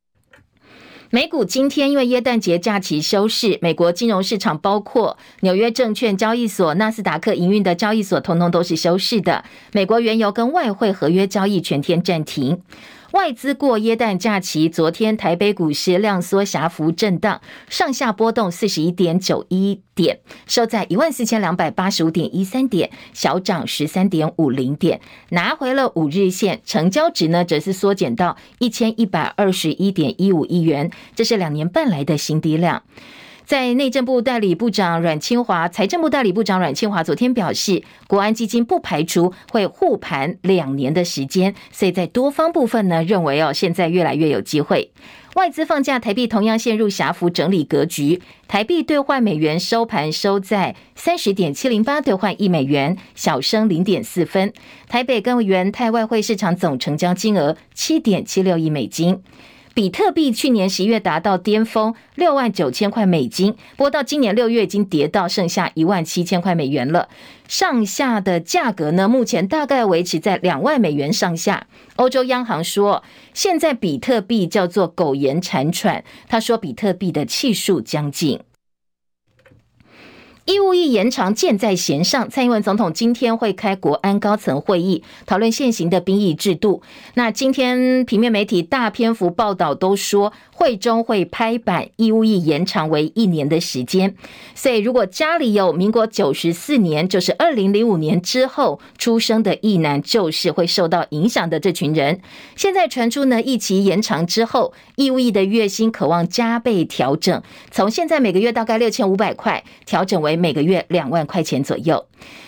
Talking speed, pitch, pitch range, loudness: 270 characters per minute, 200 Hz, 175-230 Hz, -18 LUFS